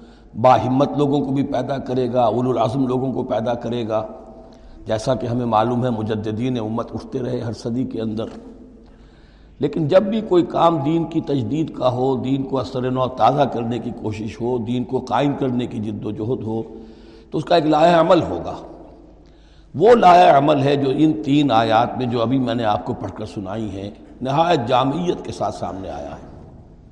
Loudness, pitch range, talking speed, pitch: -19 LUFS, 110-135 Hz, 200 wpm, 125 Hz